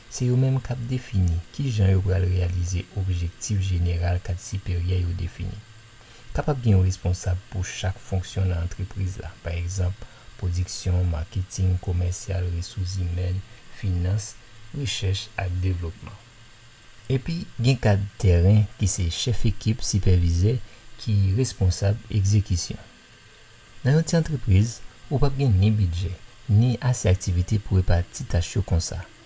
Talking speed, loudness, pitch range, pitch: 140 wpm, -25 LUFS, 90-115 Hz, 100 Hz